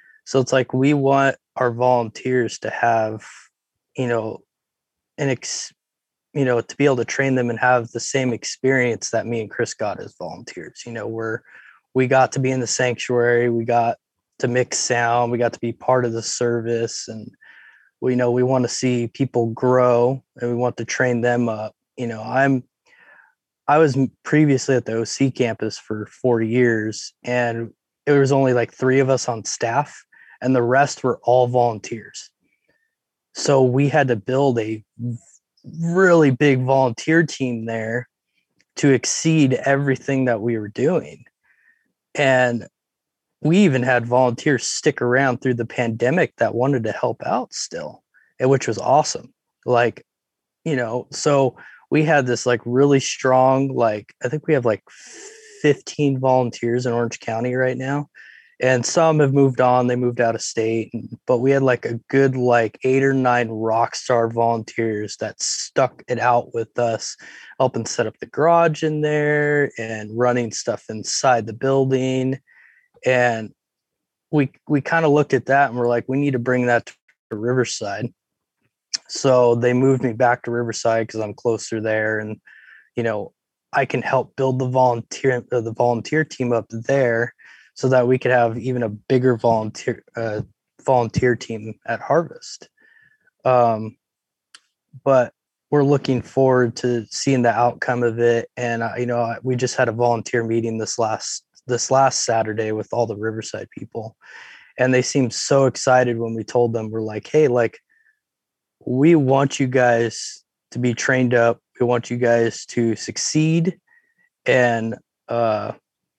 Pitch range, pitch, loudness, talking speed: 115-135 Hz, 125 Hz, -20 LUFS, 165 wpm